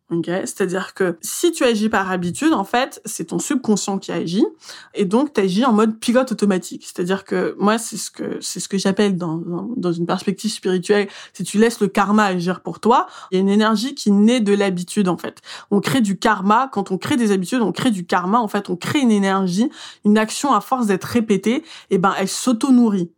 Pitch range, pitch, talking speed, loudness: 190-235 Hz, 205 Hz, 230 wpm, -19 LUFS